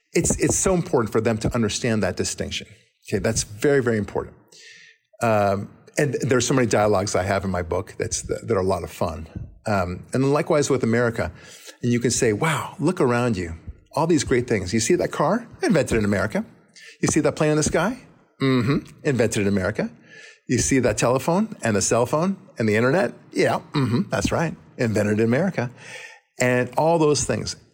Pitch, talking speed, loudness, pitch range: 120 Hz, 195 wpm, -22 LUFS, 105-140 Hz